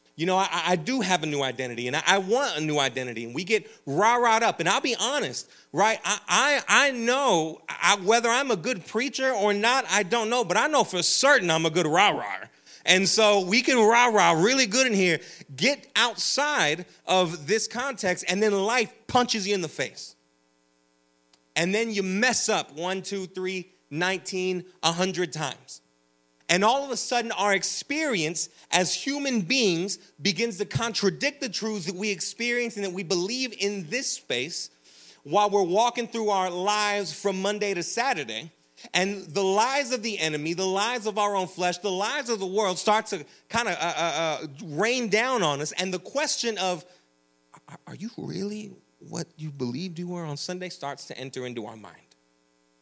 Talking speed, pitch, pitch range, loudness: 185 wpm, 190 Hz, 165-225 Hz, -25 LUFS